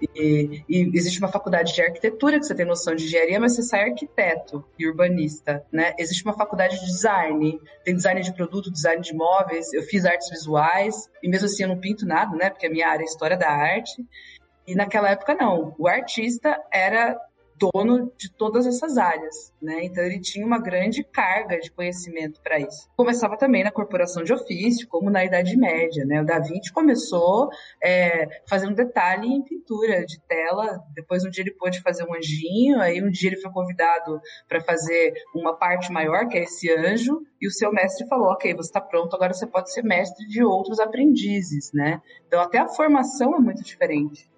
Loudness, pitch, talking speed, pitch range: -22 LUFS, 185 Hz, 195 wpm, 165-225 Hz